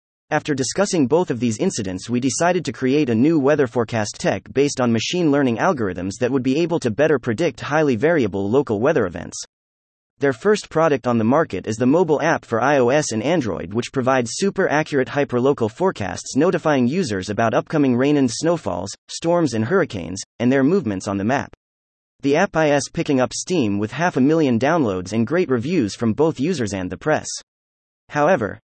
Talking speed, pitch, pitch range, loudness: 185 wpm, 130 Hz, 105-150 Hz, -20 LUFS